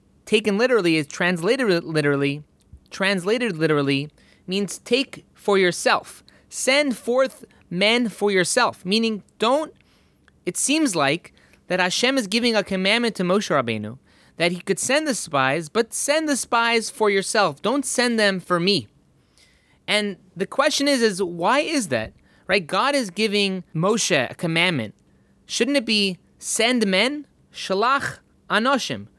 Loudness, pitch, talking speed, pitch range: -21 LUFS, 205 Hz, 140 wpm, 180-240 Hz